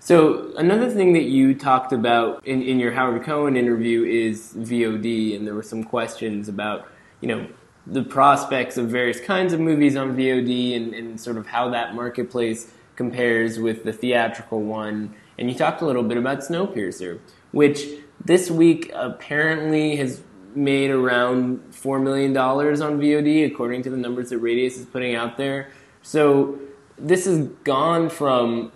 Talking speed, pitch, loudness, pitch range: 165 wpm, 125 Hz, -21 LUFS, 115-145 Hz